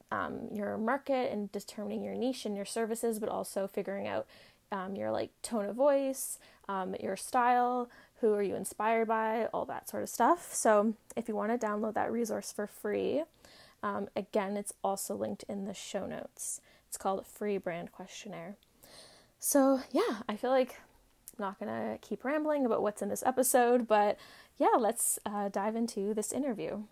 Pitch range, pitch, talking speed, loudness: 200-245 Hz, 215 Hz, 180 wpm, -33 LUFS